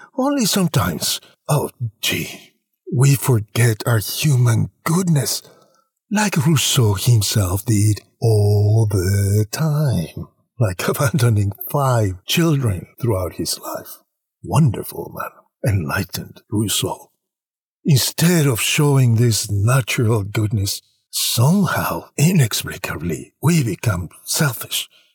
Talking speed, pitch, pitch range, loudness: 90 wpm, 120 Hz, 105-150 Hz, -18 LUFS